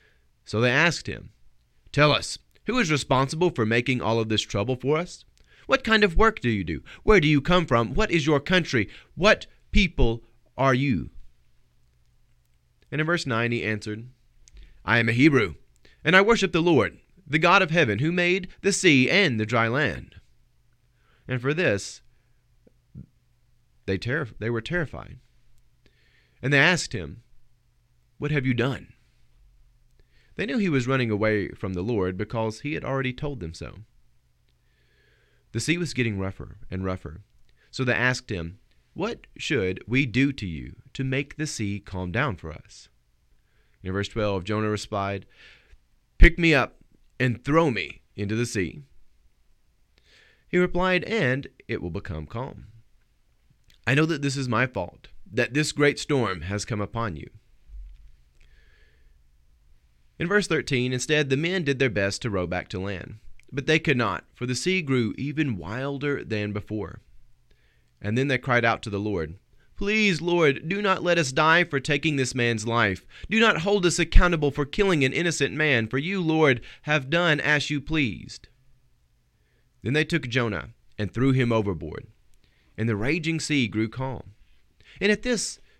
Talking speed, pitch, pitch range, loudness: 165 wpm, 120 Hz, 100-150 Hz, -24 LUFS